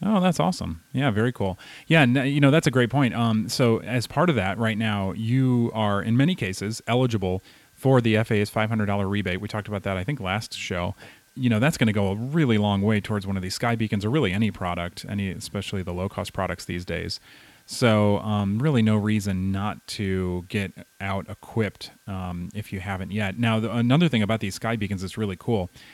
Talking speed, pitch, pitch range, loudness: 220 wpm, 105 Hz, 100-120 Hz, -24 LUFS